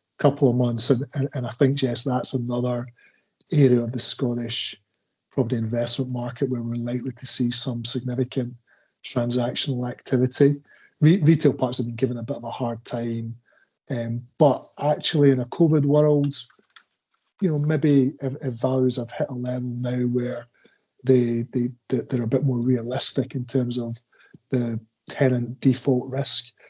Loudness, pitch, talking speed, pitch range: -23 LUFS, 125 Hz, 160 wpm, 120-135 Hz